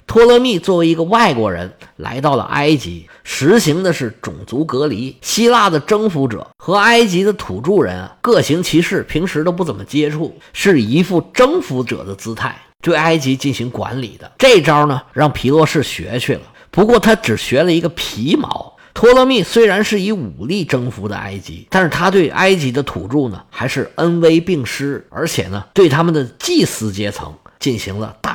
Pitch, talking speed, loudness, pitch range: 150 Hz, 280 characters per minute, -14 LUFS, 120-190 Hz